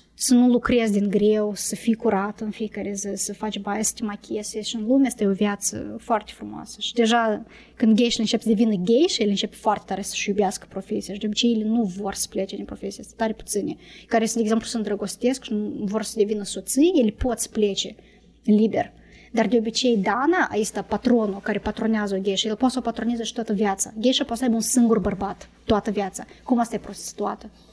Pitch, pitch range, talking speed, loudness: 215 Hz, 205-230 Hz, 220 wpm, -23 LUFS